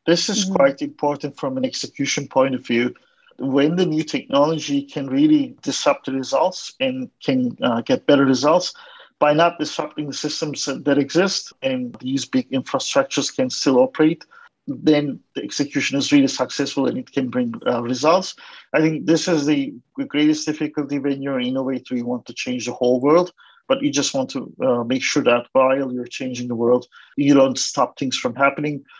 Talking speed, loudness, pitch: 185 wpm, -20 LUFS, 150 Hz